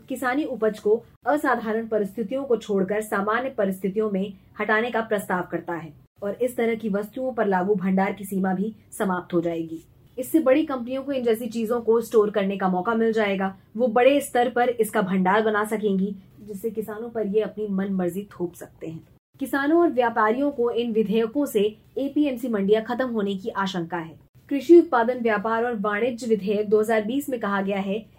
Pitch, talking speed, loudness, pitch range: 220 Hz, 185 wpm, -24 LUFS, 200-245 Hz